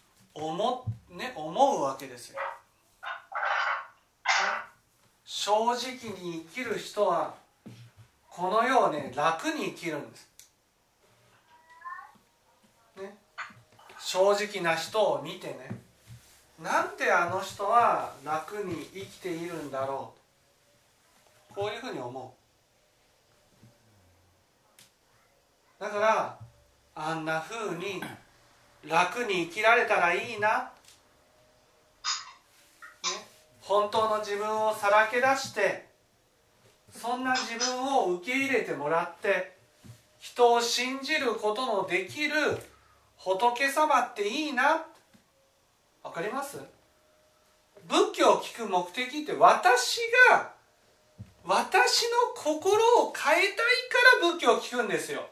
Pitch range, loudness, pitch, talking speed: 165-270 Hz, -27 LUFS, 215 Hz, 180 characters per minute